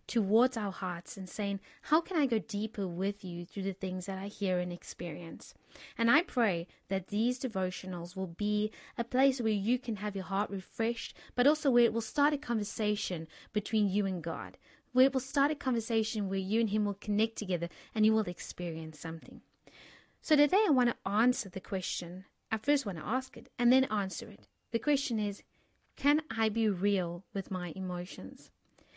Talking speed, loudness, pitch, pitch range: 195 wpm, -32 LUFS, 210 Hz, 190-240 Hz